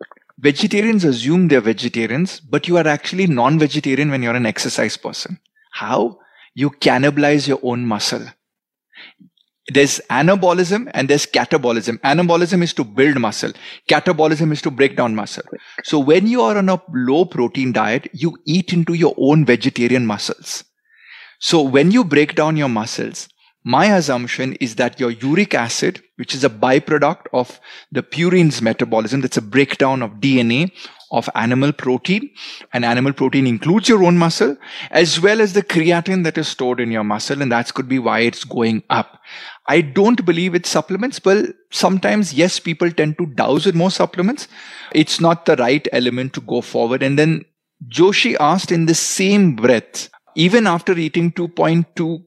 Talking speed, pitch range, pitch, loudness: 165 wpm, 130-180 Hz, 155 Hz, -16 LUFS